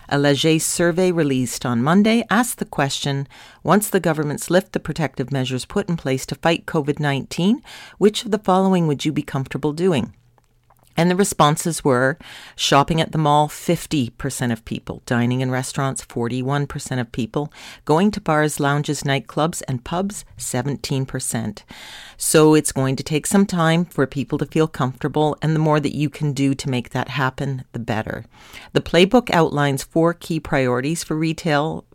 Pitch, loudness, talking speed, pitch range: 150 Hz, -20 LUFS, 170 wpm, 135-165 Hz